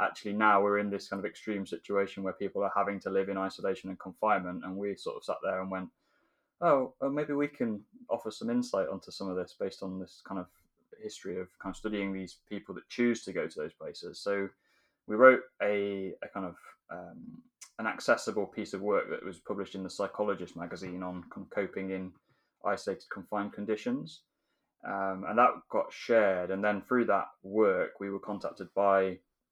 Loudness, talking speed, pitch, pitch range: -32 LUFS, 200 wpm, 100 Hz, 95-115 Hz